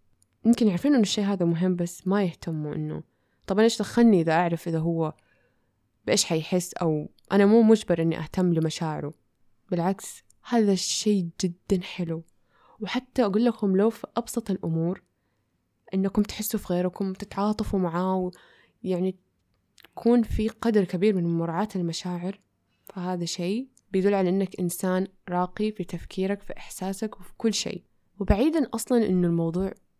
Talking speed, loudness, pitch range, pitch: 140 wpm, -26 LUFS, 170-210 Hz, 185 Hz